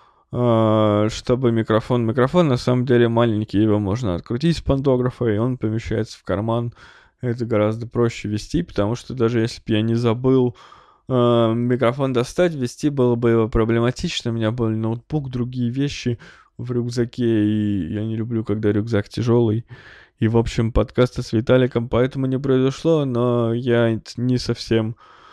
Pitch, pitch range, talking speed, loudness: 120 Hz, 110-125 Hz, 155 wpm, -20 LUFS